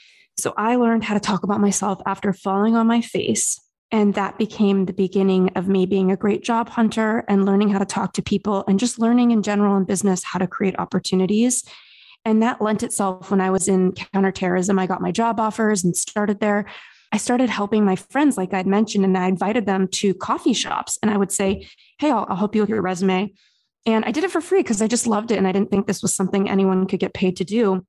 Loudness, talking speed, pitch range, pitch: -20 LUFS, 240 wpm, 190-220 Hz, 200 Hz